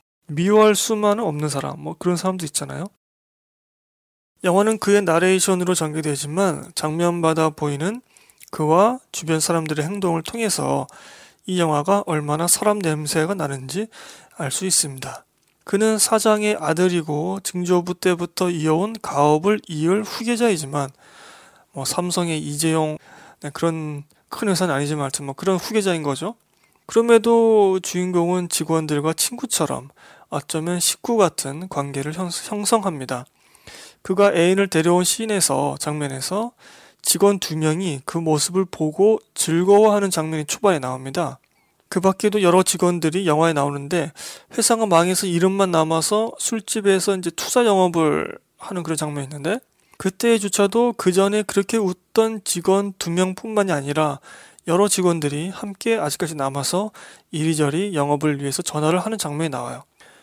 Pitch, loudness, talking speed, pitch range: 180 Hz, -20 LUFS, 315 characters per minute, 155-200 Hz